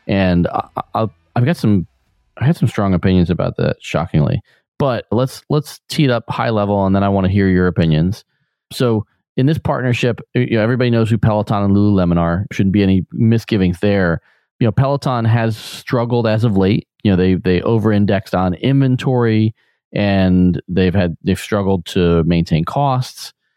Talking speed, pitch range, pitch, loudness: 180 wpm, 95-120 Hz, 105 Hz, -16 LUFS